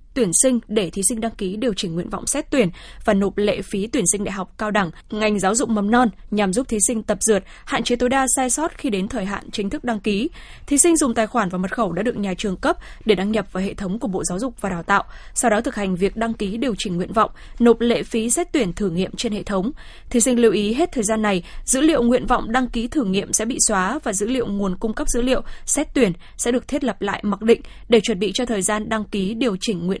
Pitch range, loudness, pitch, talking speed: 200-245 Hz, -20 LUFS, 220 Hz, 285 wpm